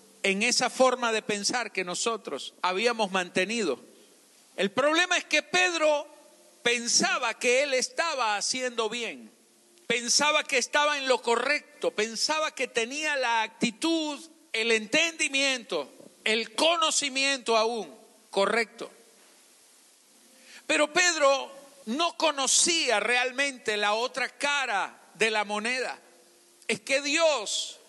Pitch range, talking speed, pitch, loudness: 225-295 Hz, 110 wpm, 250 Hz, -26 LUFS